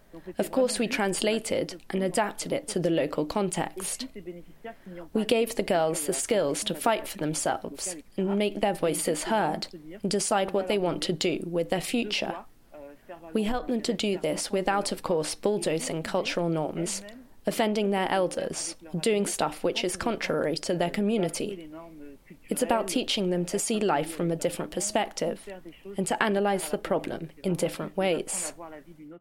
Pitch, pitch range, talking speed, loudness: 190 Hz, 170-210 Hz, 160 wpm, -28 LUFS